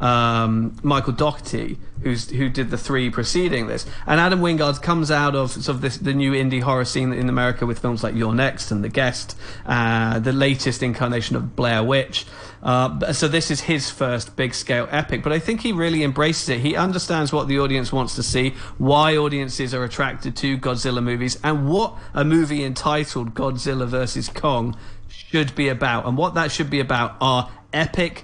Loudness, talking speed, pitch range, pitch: -21 LUFS, 195 wpm, 120-150 Hz, 130 Hz